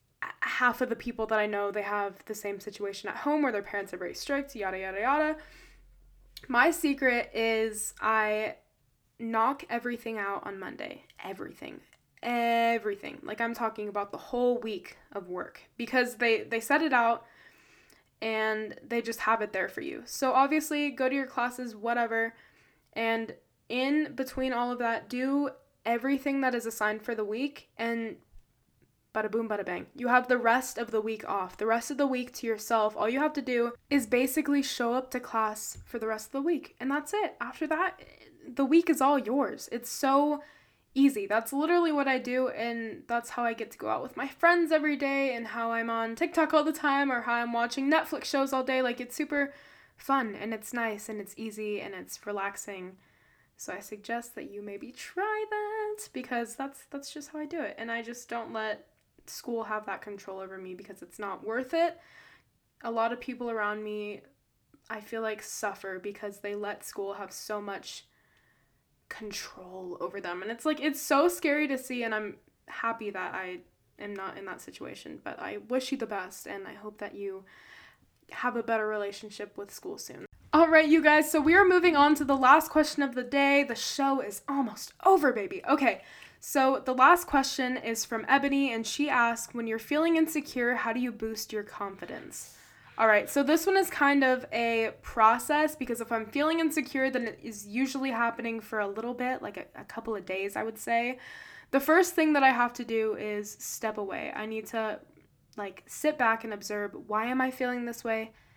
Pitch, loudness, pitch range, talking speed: 235 Hz, -29 LUFS, 215-280 Hz, 200 wpm